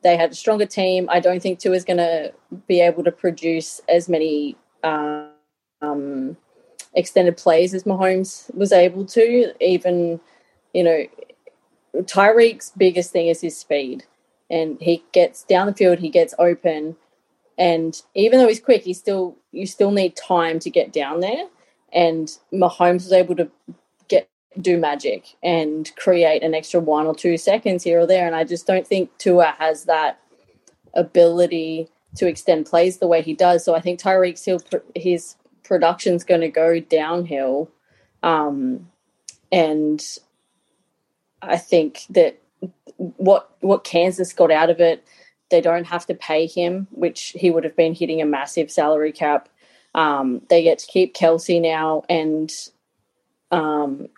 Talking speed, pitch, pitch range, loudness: 155 wpm, 175 Hz, 160-185 Hz, -19 LUFS